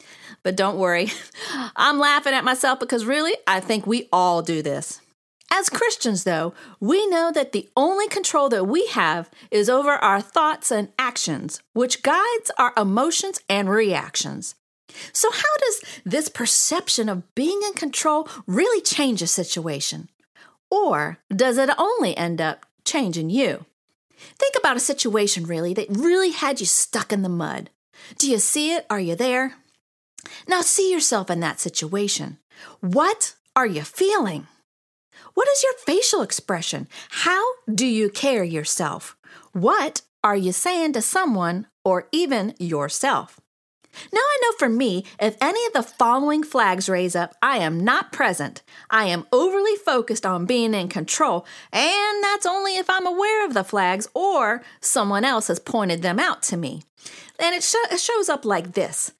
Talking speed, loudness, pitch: 160 wpm, -21 LUFS, 255 Hz